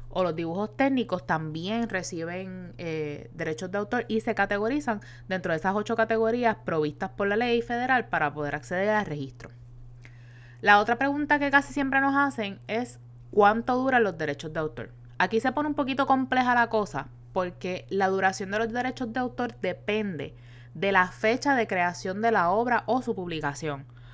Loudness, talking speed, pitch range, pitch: -27 LUFS, 175 wpm, 155-235 Hz, 195 Hz